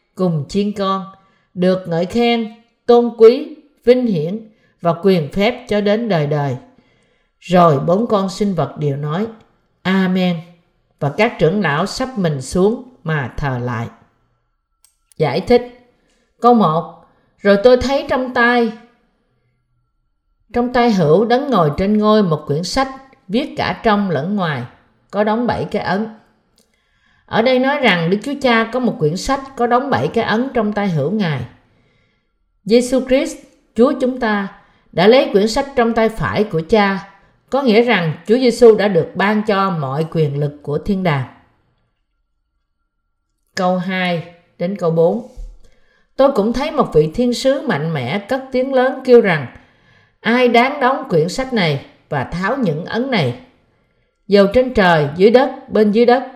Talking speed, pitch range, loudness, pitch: 160 wpm, 160-240 Hz, -16 LUFS, 205 Hz